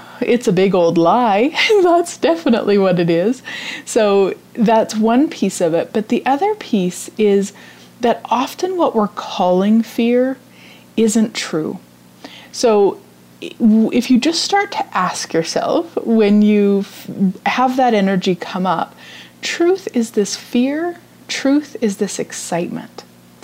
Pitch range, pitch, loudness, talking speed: 195-265 Hz, 225 Hz, -16 LUFS, 135 wpm